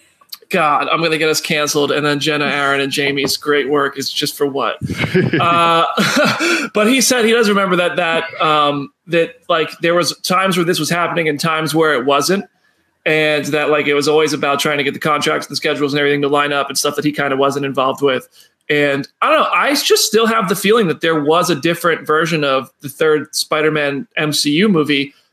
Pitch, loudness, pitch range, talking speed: 155 Hz, -15 LUFS, 145-170 Hz, 225 wpm